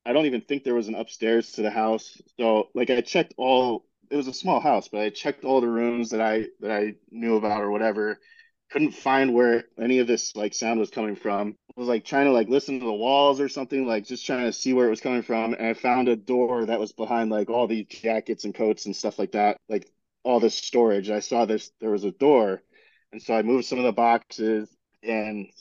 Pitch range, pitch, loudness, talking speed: 110-125 Hz, 115 Hz, -24 LUFS, 250 wpm